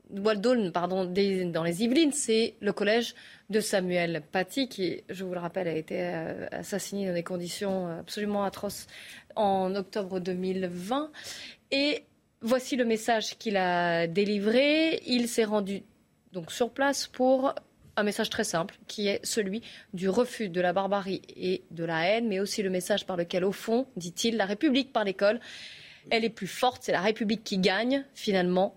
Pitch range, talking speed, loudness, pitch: 185-230 Hz, 165 wpm, -29 LUFS, 205 Hz